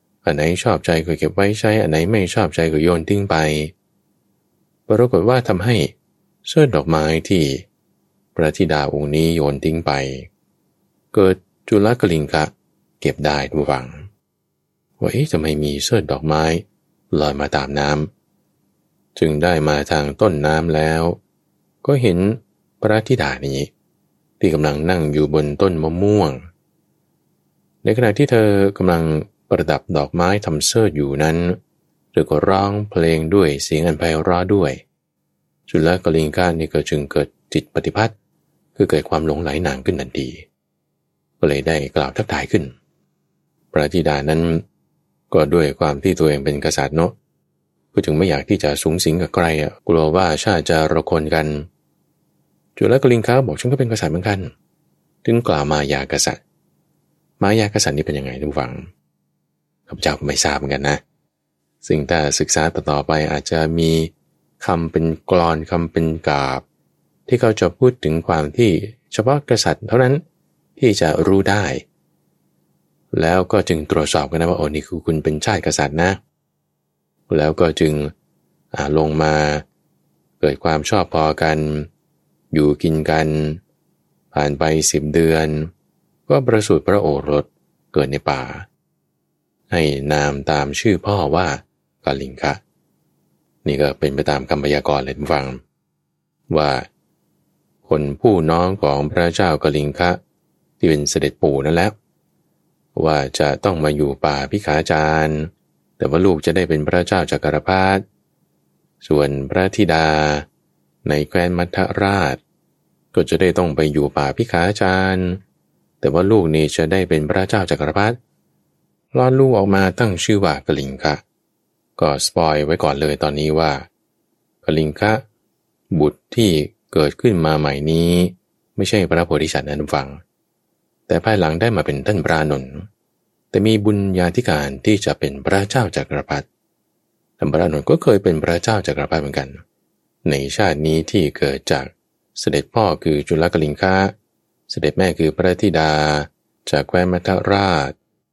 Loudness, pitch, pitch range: -18 LUFS, 80 Hz, 75-95 Hz